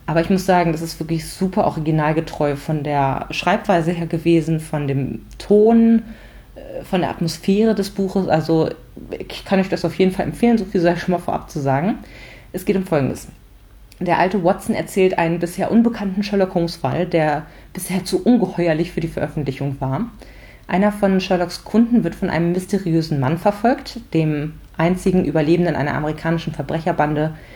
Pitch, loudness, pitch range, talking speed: 170 Hz, -19 LUFS, 155-190 Hz, 170 wpm